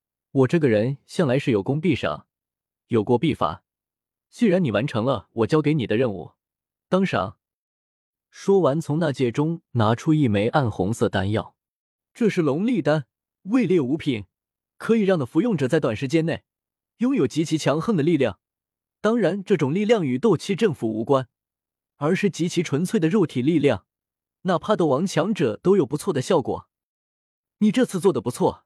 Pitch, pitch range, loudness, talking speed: 155 Hz, 125-190 Hz, -22 LUFS, 250 characters per minute